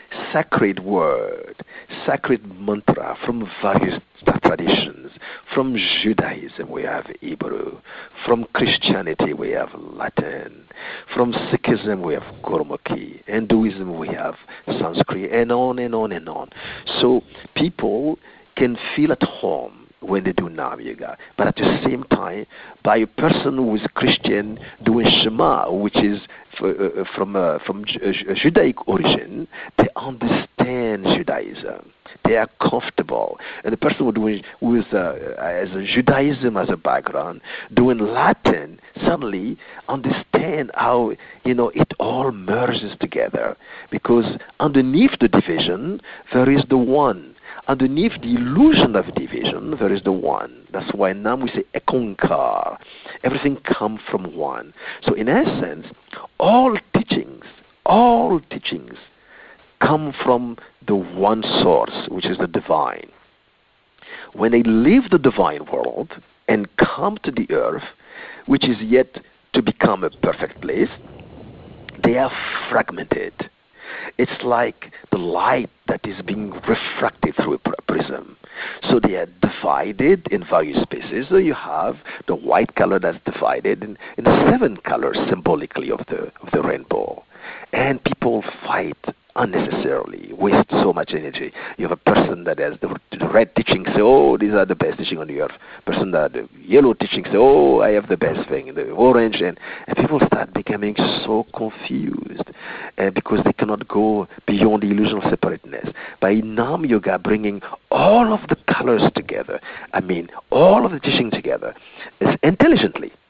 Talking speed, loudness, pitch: 145 wpm, -19 LUFS, 125 Hz